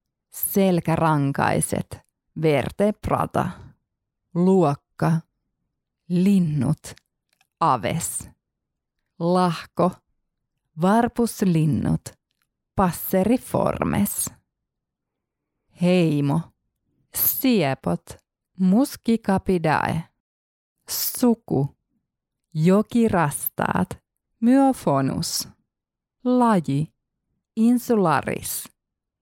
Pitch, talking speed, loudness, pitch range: 175 Hz, 35 wpm, -22 LUFS, 145-205 Hz